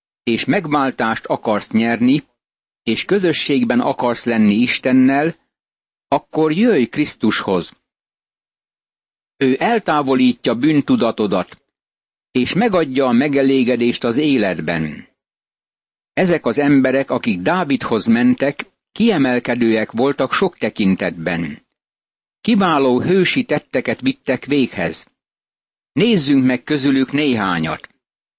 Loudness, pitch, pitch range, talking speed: -17 LUFS, 135 Hz, 120-165 Hz, 85 wpm